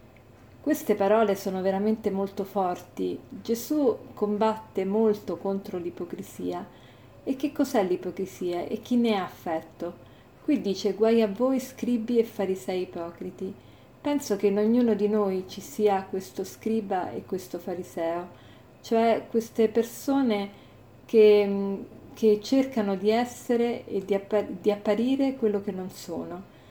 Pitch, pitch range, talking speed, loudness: 205 Hz, 185-225 Hz, 135 wpm, -27 LUFS